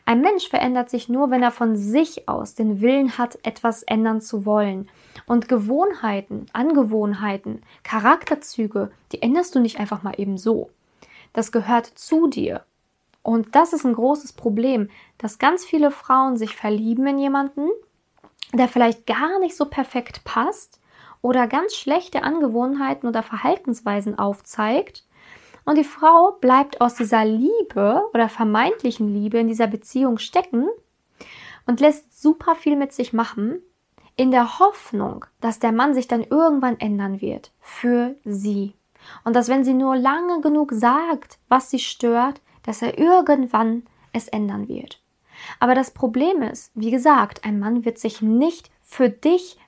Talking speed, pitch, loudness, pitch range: 150 wpm, 245 Hz, -20 LUFS, 225-290 Hz